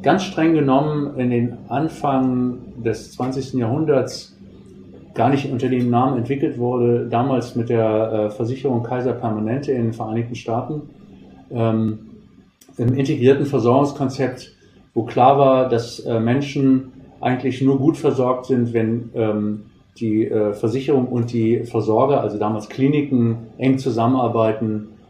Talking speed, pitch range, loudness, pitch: 130 wpm, 115-135 Hz, -19 LUFS, 125 Hz